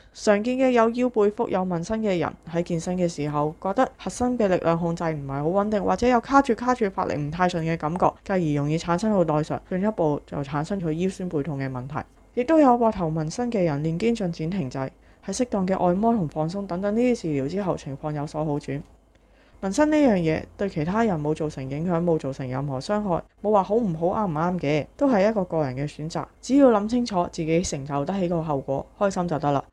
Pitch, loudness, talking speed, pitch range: 175 Hz, -24 LUFS, 335 characters per minute, 150-210 Hz